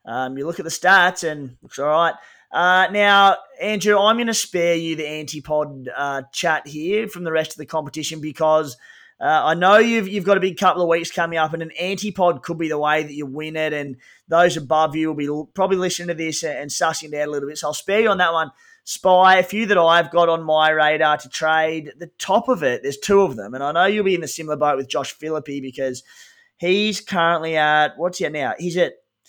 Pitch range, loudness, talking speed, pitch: 150-190 Hz, -19 LUFS, 250 wpm, 165 Hz